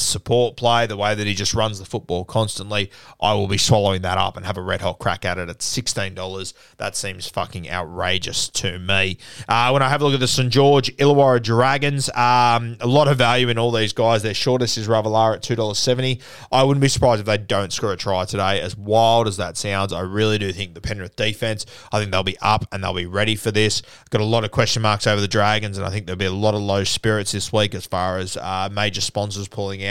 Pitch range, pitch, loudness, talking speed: 95-120 Hz, 105 Hz, -20 LUFS, 245 wpm